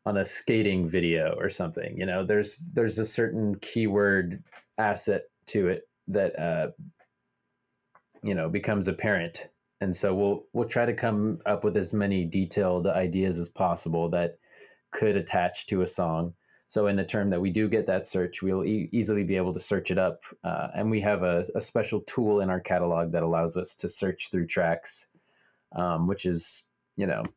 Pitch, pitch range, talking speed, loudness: 95 Hz, 90-110 Hz, 185 wpm, -28 LUFS